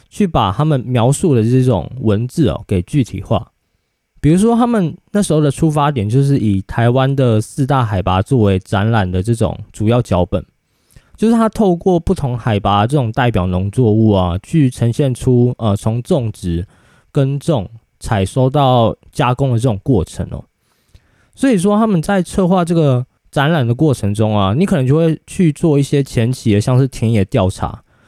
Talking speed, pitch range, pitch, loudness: 265 characters per minute, 105-150 Hz, 125 Hz, -15 LUFS